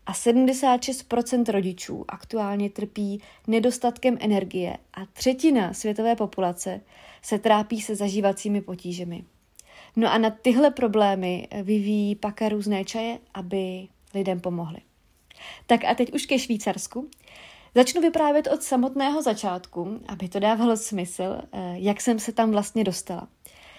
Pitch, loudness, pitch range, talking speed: 215 Hz, -25 LUFS, 195-240 Hz, 125 wpm